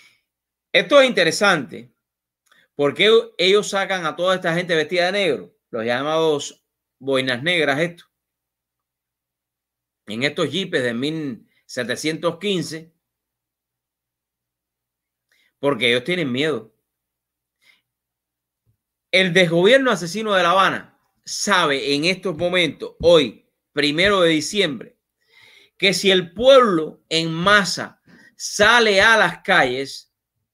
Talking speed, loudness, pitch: 100 wpm, -18 LUFS, 155 Hz